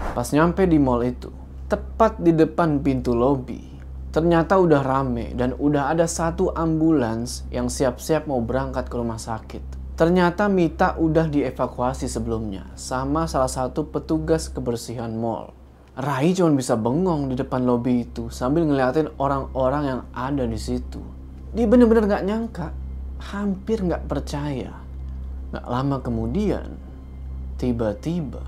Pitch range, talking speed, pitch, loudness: 100-160 Hz, 130 wpm, 130 Hz, -22 LUFS